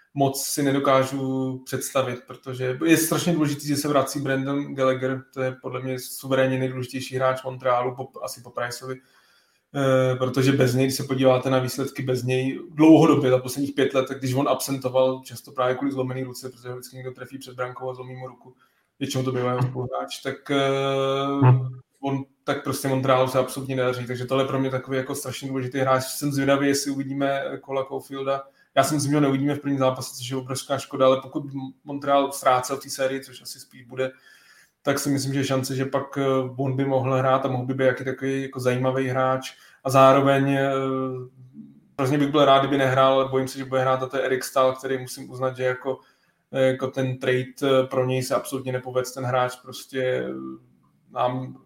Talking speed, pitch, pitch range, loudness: 195 wpm, 130 Hz, 130-135 Hz, -23 LUFS